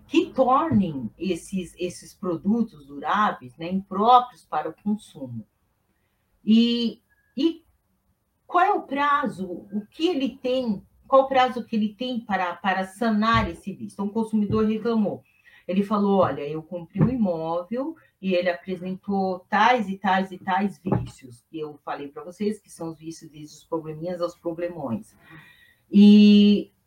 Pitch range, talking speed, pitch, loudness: 170-225 Hz, 150 wpm, 195 Hz, -23 LUFS